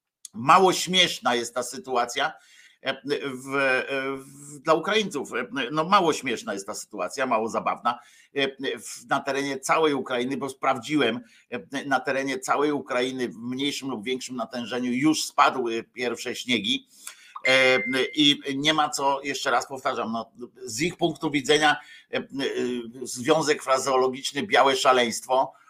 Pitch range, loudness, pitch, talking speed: 130-155 Hz, -24 LUFS, 135 Hz, 120 wpm